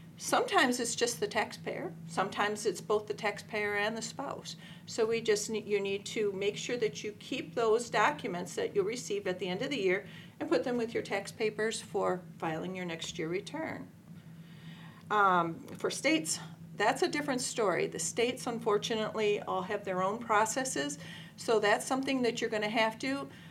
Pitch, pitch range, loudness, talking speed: 205 Hz, 180-225 Hz, -32 LUFS, 185 wpm